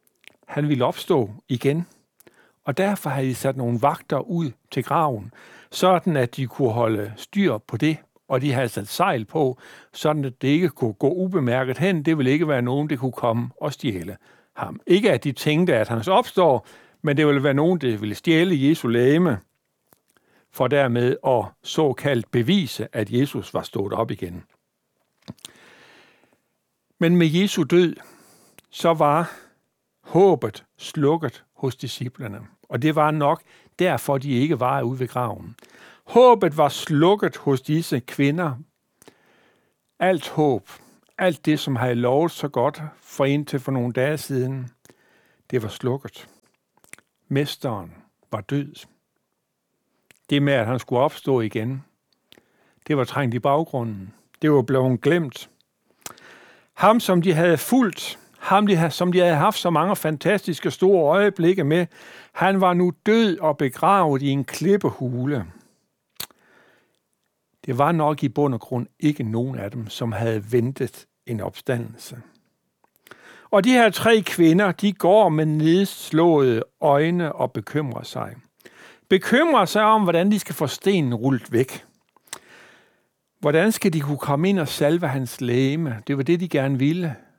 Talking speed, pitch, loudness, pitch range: 150 wpm, 145 Hz, -21 LUFS, 125-170 Hz